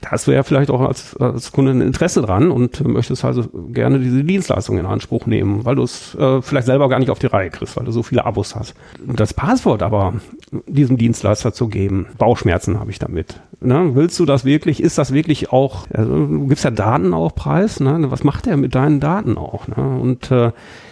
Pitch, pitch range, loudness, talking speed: 130 Hz, 115-140 Hz, -17 LUFS, 220 wpm